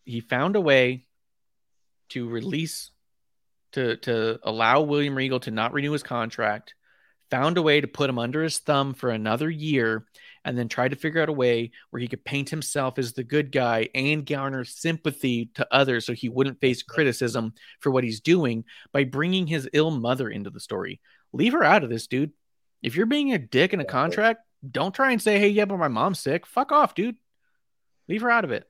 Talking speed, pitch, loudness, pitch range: 205 wpm, 135 Hz, -24 LUFS, 120-160 Hz